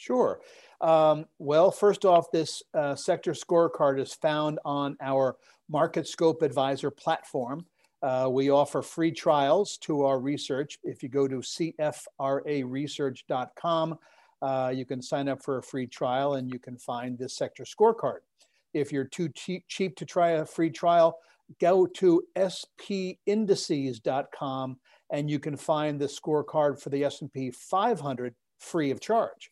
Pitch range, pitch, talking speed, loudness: 135-170 Hz, 150 Hz, 145 wpm, -28 LUFS